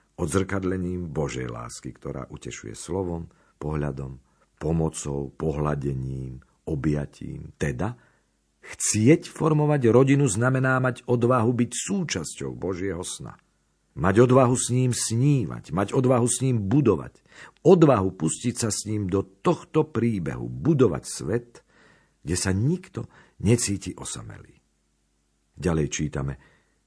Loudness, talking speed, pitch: -24 LUFS, 105 wpm, 95 Hz